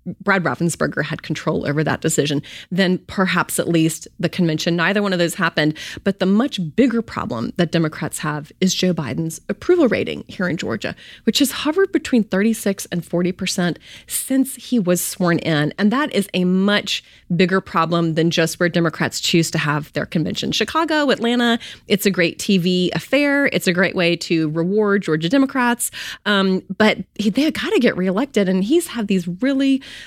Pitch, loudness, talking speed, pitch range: 185 Hz, -19 LUFS, 180 wpm, 165-225 Hz